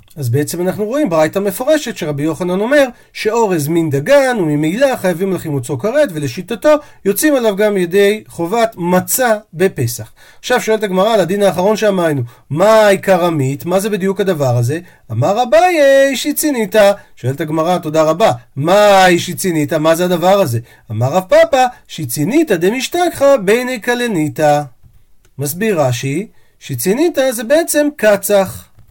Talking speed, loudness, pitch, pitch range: 135 wpm, -13 LUFS, 190 Hz, 155-230 Hz